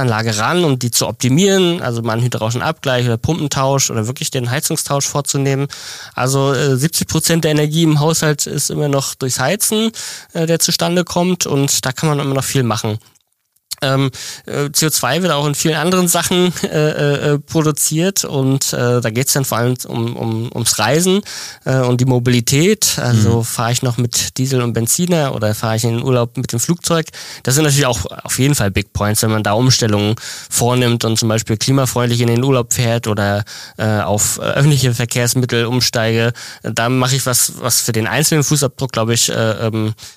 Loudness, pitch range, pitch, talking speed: -15 LUFS, 115-150 Hz, 130 Hz, 175 wpm